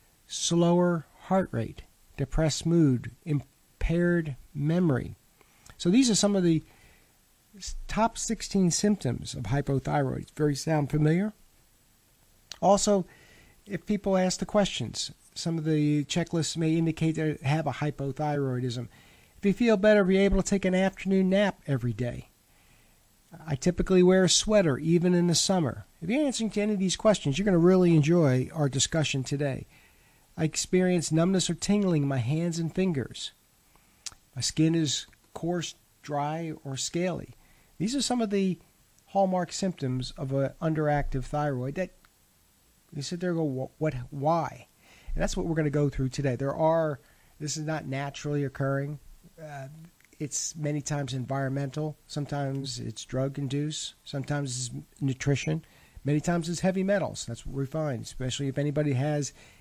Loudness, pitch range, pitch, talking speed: -28 LUFS, 140-180 Hz, 155 Hz, 155 wpm